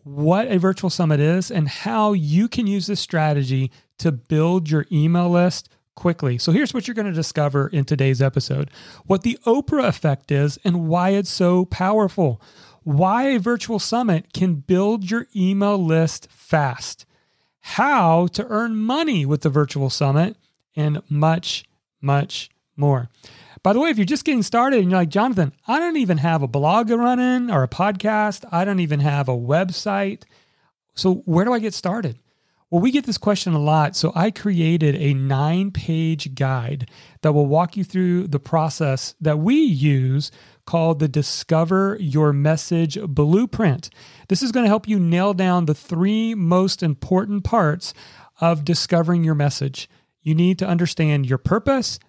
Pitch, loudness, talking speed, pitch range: 170 Hz, -20 LUFS, 170 wpm, 150-200 Hz